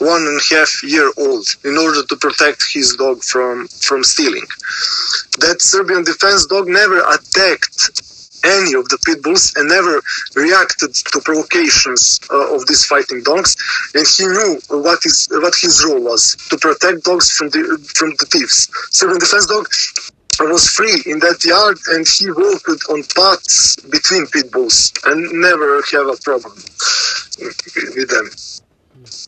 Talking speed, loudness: 155 wpm, -11 LUFS